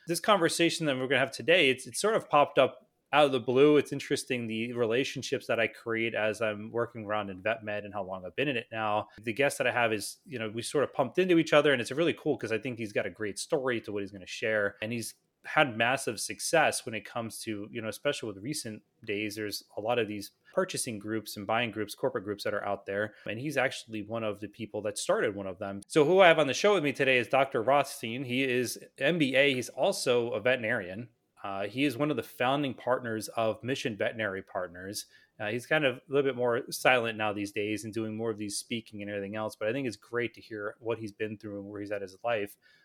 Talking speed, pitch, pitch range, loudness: 260 wpm, 115 Hz, 105-135 Hz, -30 LUFS